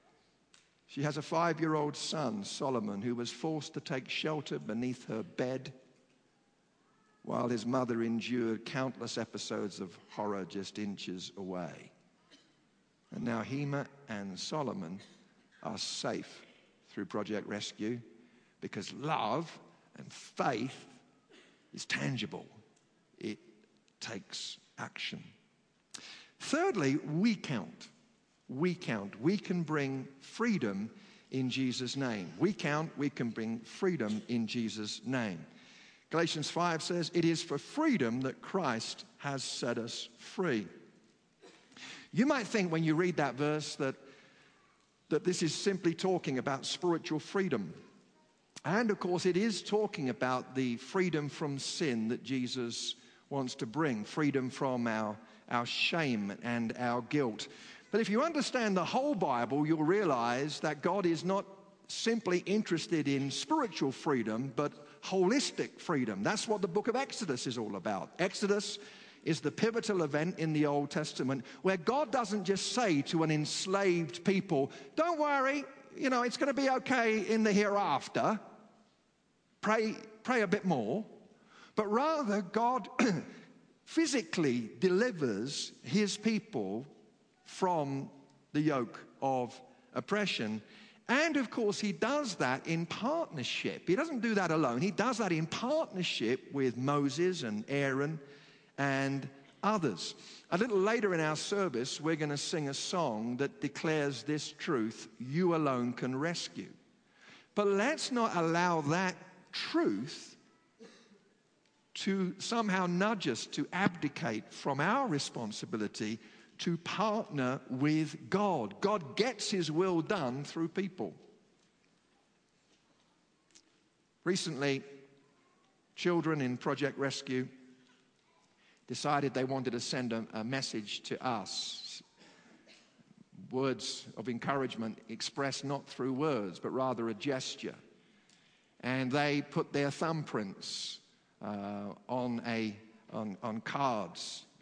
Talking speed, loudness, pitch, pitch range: 125 wpm, -34 LUFS, 155 Hz, 130-200 Hz